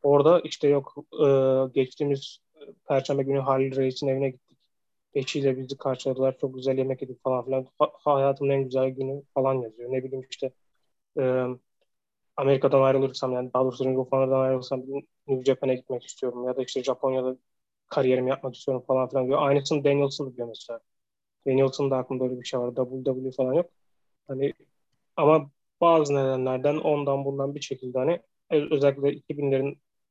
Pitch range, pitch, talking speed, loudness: 130-140 Hz, 135 Hz, 150 wpm, -26 LUFS